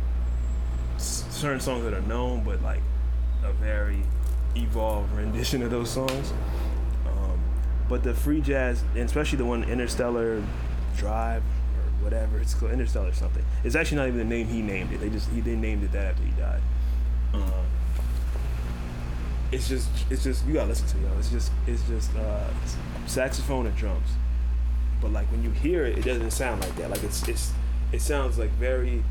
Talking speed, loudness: 175 wpm, -28 LUFS